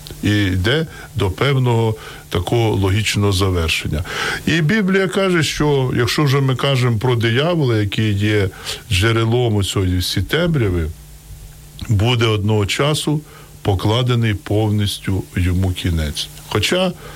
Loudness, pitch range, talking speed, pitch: -17 LUFS, 100-140 Hz, 110 wpm, 110 Hz